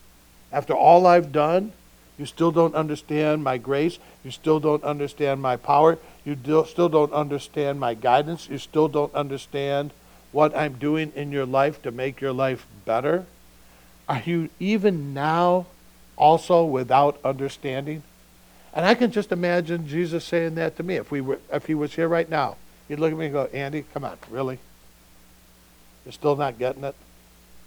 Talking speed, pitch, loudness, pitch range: 170 wpm, 145 Hz, -23 LUFS, 130-160 Hz